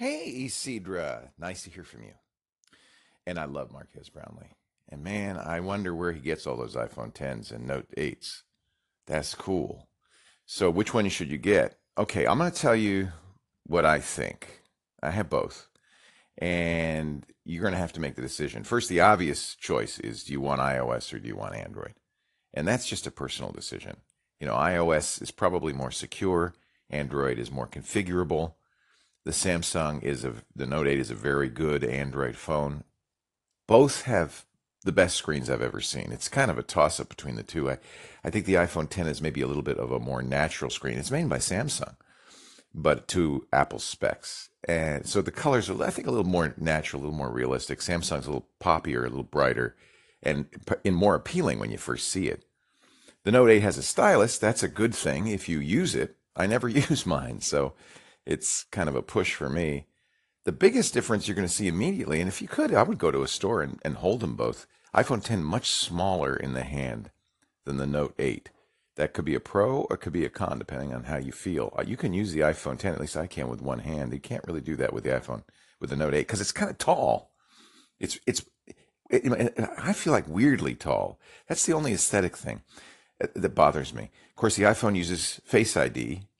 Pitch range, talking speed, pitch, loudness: 70-95 Hz, 205 wpm, 80 Hz, -28 LUFS